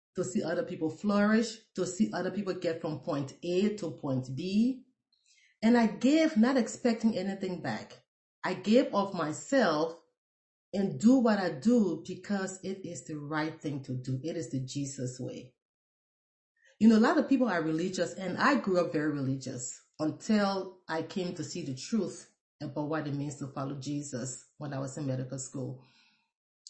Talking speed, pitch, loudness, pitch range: 180 wpm, 170 Hz, -31 LUFS, 145-205 Hz